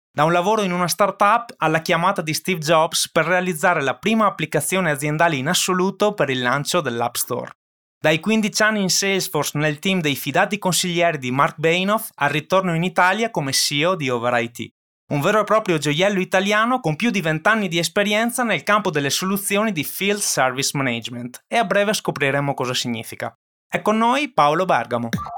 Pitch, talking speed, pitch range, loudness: 175 Hz, 180 wpm, 145-200 Hz, -19 LUFS